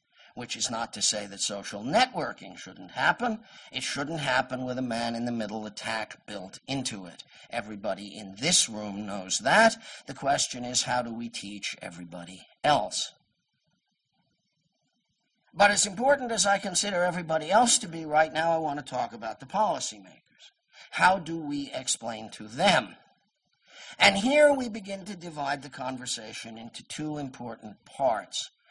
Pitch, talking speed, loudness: 140 Hz, 155 wpm, -27 LUFS